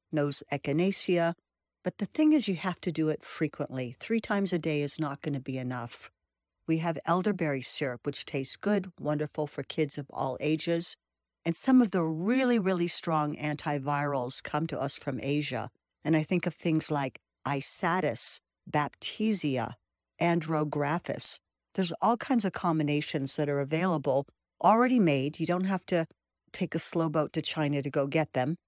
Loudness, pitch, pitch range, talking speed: -30 LUFS, 155 Hz, 145-175 Hz, 170 wpm